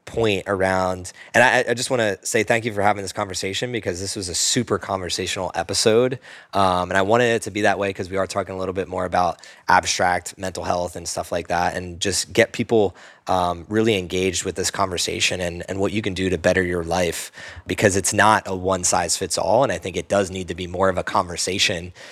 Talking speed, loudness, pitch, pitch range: 235 wpm, -21 LUFS, 95 Hz, 90-100 Hz